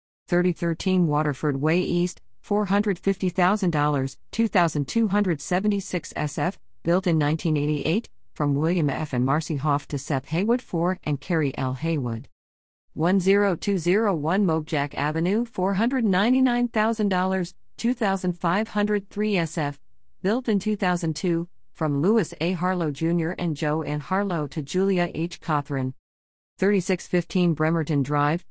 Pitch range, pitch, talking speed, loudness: 150-195 Hz, 175 Hz, 105 wpm, -24 LUFS